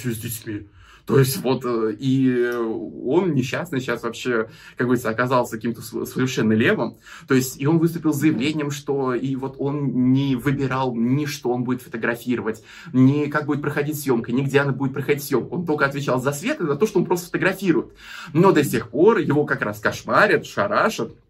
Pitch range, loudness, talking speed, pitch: 120-145 Hz, -21 LUFS, 185 wpm, 130 Hz